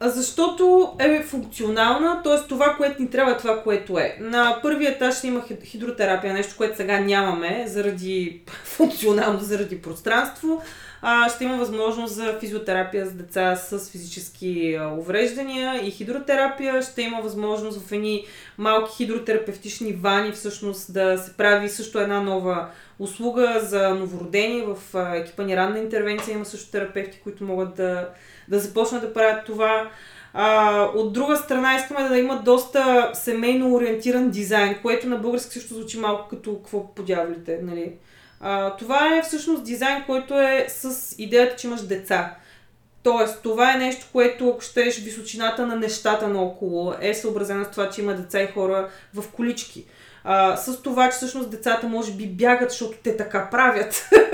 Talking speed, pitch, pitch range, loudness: 155 wpm, 220 Hz, 200-245 Hz, -22 LUFS